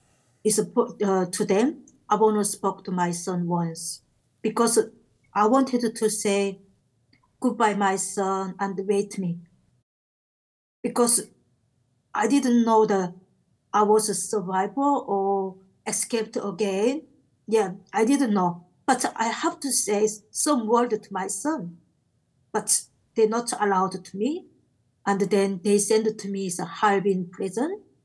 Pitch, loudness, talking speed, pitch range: 205 Hz, -24 LUFS, 135 wpm, 190-230 Hz